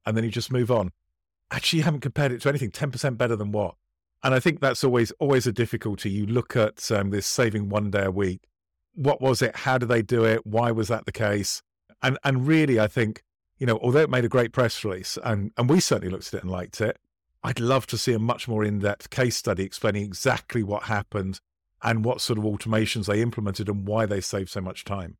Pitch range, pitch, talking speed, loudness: 100-125 Hz, 110 Hz, 240 wpm, -25 LUFS